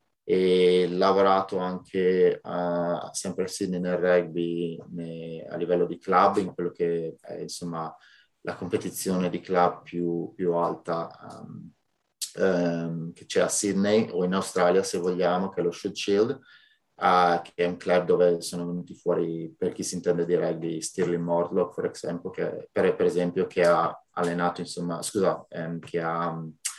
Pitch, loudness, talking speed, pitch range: 90 Hz, -26 LUFS, 165 wpm, 85-90 Hz